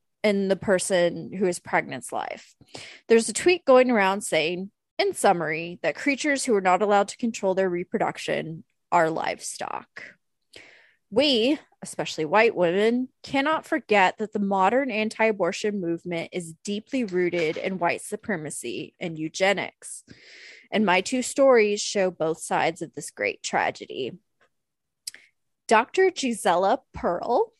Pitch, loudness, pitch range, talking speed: 205 Hz, -24 LUFS, 180-250 Hz, 135 wpm